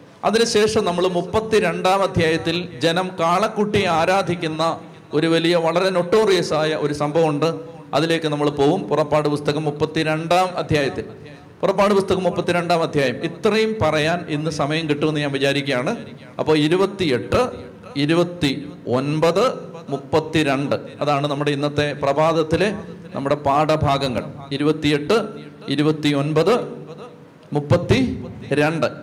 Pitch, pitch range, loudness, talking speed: 155 Hz, 145-175 Hz, -20 LUFS, 105 wpm